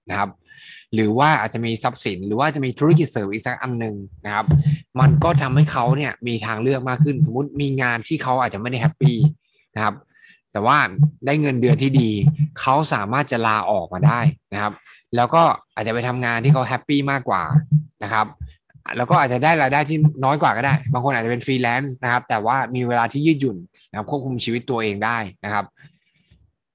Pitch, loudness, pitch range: 130 Hz, -20 LUFS, 115-150 Hz